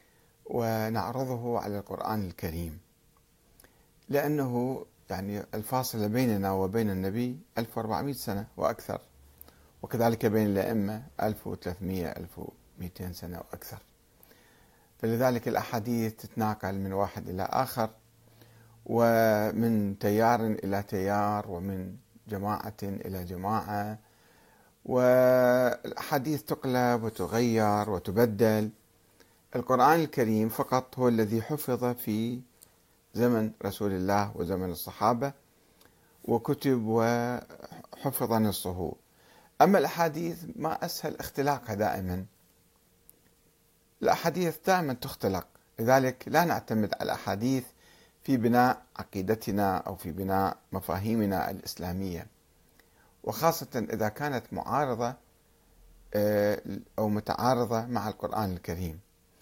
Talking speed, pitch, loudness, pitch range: 85 wpm, 110 Hz, -29 LUFS, 95-120 Hz